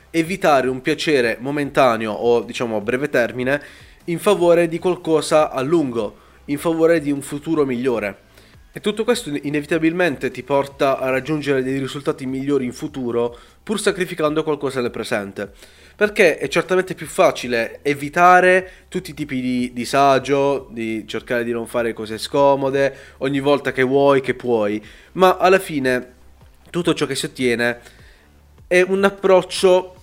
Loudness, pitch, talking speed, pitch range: -19 LUFS, 140 Hz, 150 wpm, 125-165 Hz